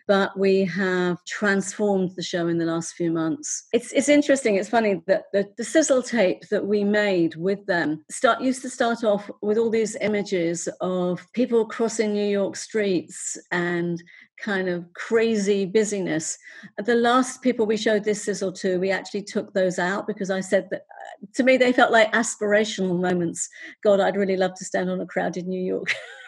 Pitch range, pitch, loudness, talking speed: 185-225 Hz, 200 Hz, -23 LUFS, 185 wpm